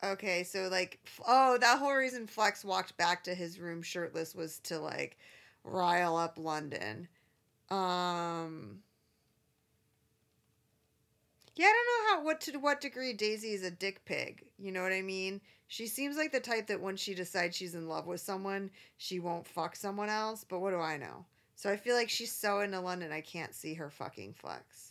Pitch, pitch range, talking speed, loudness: 190 Hz, 170-220 Hz, 190 wpm, -34 LUFS